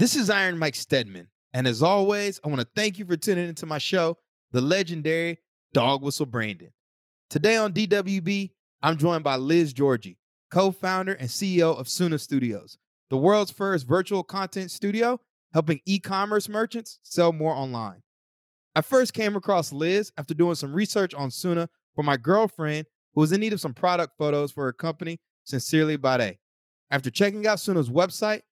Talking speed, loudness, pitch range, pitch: 170 wpm, -25 LUFS, 140-195 Hz, 165 Hz